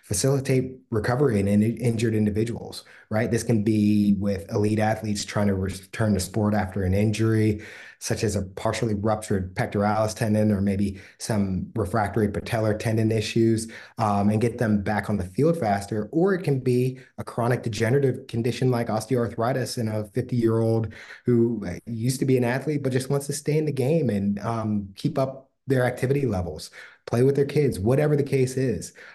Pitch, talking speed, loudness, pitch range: 115 Hz, 180 wpm, -24 LUFS, 105-130 Hz